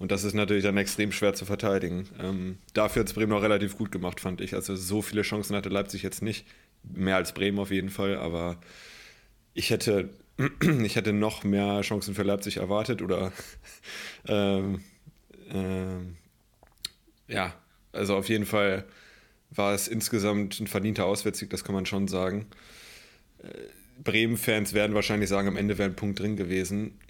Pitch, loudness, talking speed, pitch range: 100 Hz, -28 LUFS, 165 wpm, 95-105 Hz